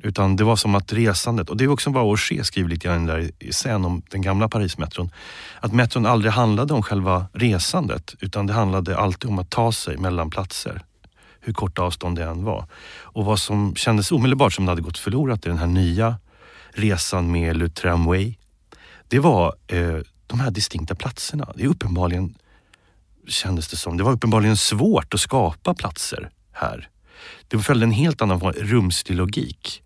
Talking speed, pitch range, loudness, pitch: 185 wpm, 90-115 Hz, -21 LUFS, 100 Hz